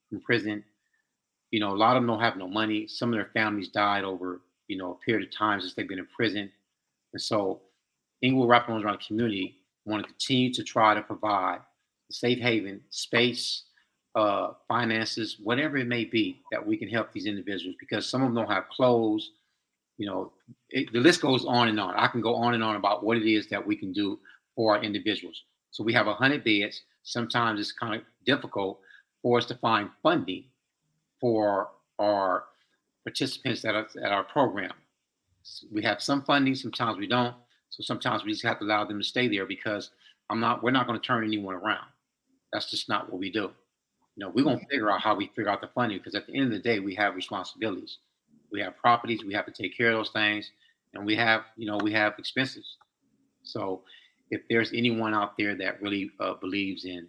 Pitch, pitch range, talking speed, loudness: 115 Hz, 105-125 Hz, 215 wpm, -28 LUFS